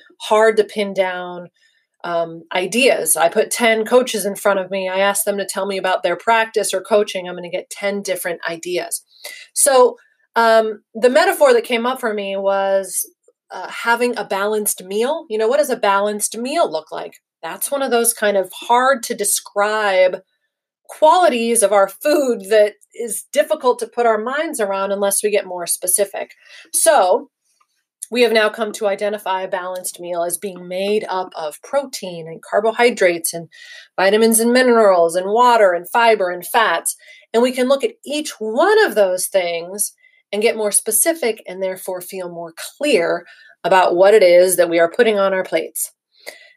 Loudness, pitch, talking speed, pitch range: -17 LUFS, 210 Hz, 180 wpm, 185-240 Hz